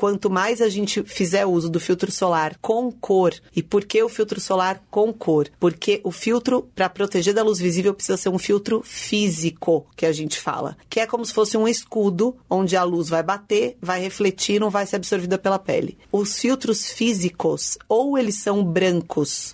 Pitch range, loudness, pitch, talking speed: 185-220 Hz, -21 LUFS, 200 Hz, 195 wpm